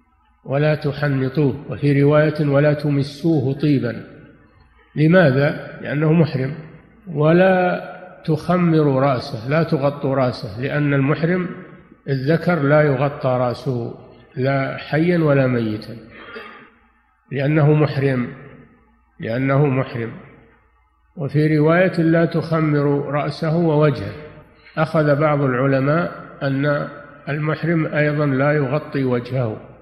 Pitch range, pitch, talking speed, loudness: 135-155 Hz, 145 Hz, 90 wpm, -18 LUFS